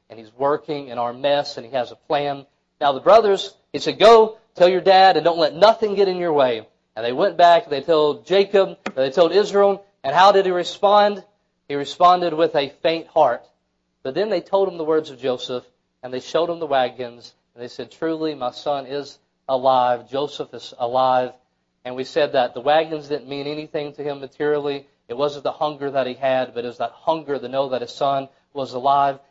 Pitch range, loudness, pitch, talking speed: 135-175 Hz, -19 LUFS, 145 Hz, 220 wpm